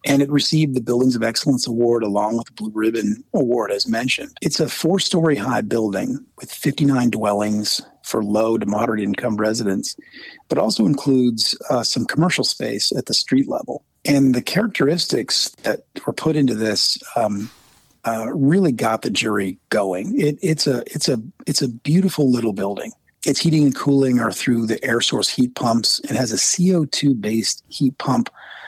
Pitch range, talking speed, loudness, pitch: 110-145 Hz, 175 wpm, -19 LUFS, 125 Hz